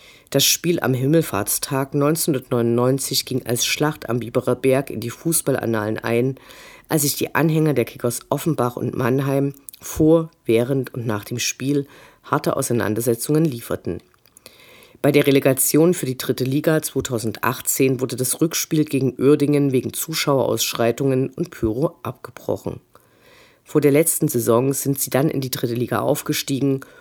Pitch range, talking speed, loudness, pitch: 120-150 Hz, 140 wpm, -20 LUFS, 135 Hz